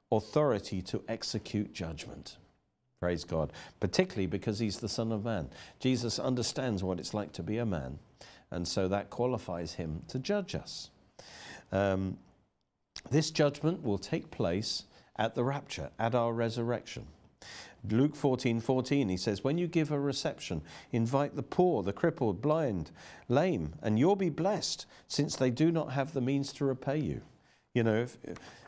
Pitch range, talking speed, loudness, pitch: 95-140 Hz, 160 wpm, -33 LUFS, 115 Hz